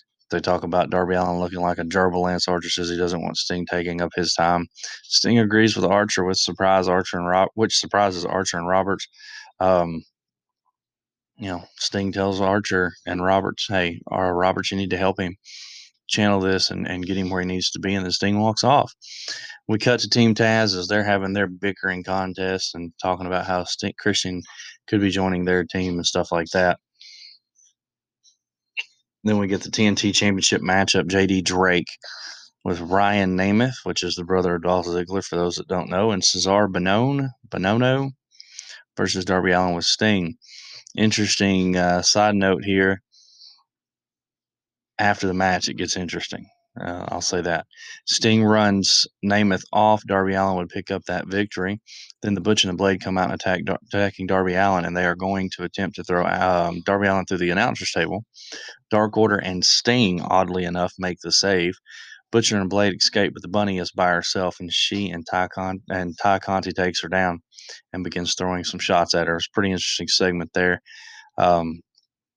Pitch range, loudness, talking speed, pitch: 90-100 Hz, -21 LUFS, 185 wpm, 95 Hz